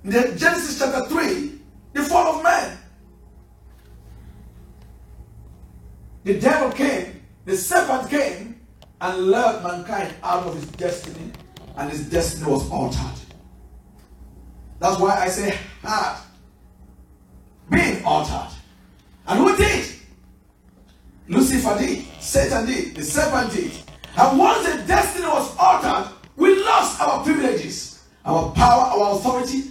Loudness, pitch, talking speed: -20 LUFS, 205 Hz, 115 wpm